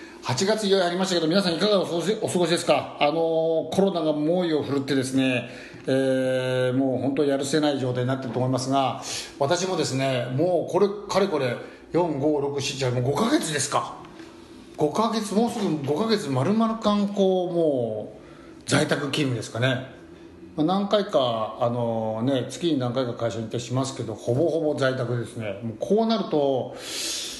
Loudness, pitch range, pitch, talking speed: -24 LUFS, 130-175 Hz, 145 Hz, 300 characters per minute